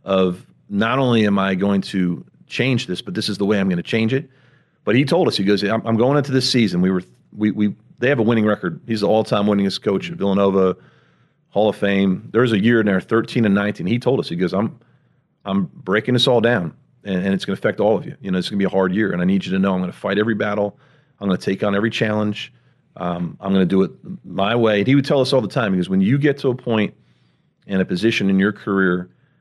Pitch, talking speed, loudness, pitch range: 100 Hz, 270 wpm, -19 LUFS, 95-115 Hz